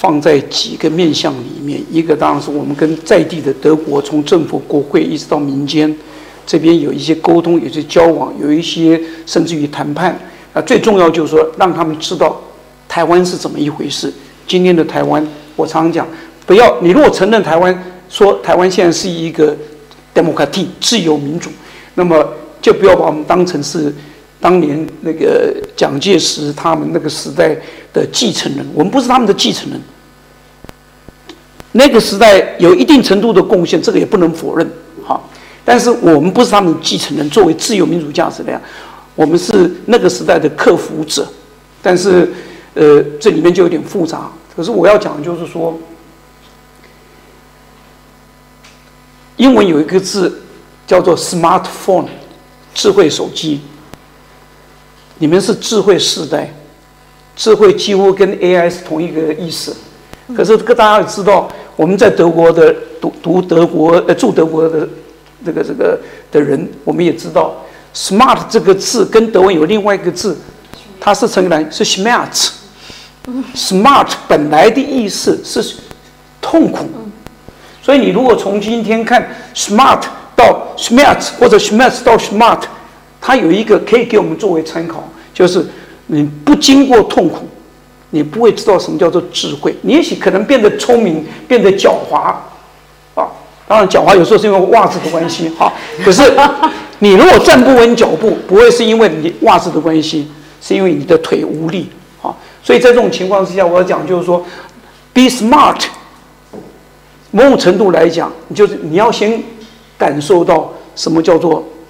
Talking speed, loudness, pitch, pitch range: 270 characters per minute, -10 LUFS, 180 Hz, 160-230 Hz